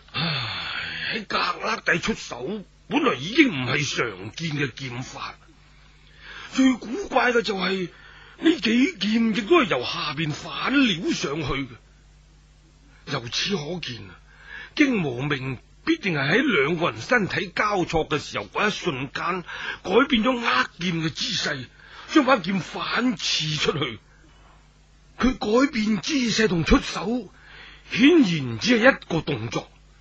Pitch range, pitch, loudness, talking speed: 150-245 Hz, 190 Hz, -23 LUFS, 190 characters per minute